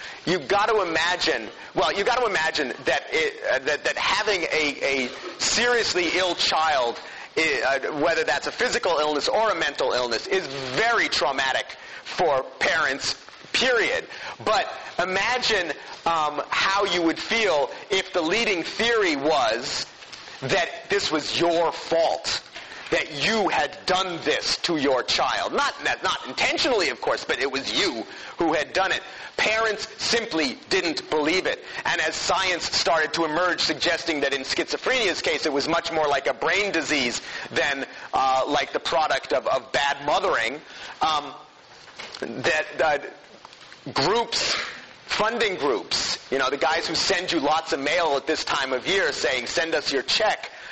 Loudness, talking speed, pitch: -23 LUFS, 155 wpm, 220 Hz